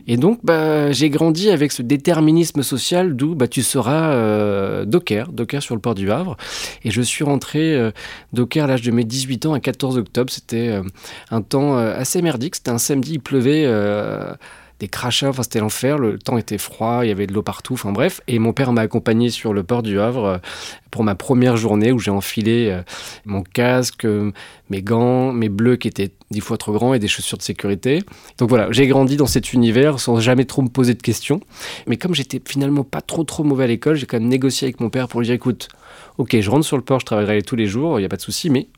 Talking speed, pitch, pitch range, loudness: 235 wpm, 125 Hz, 110-140 Hz, -18 LUFS